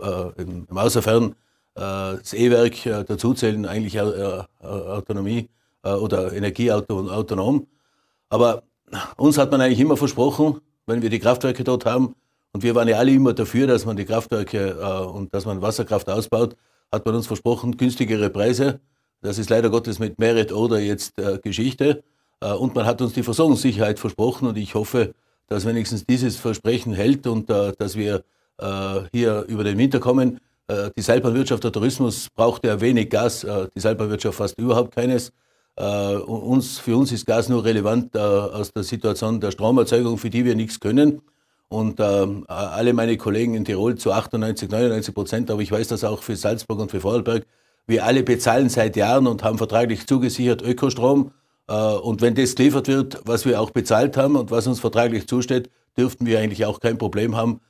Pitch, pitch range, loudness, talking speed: 115 Hz, 105-125 Hz, -21 LUFS, 175 wpm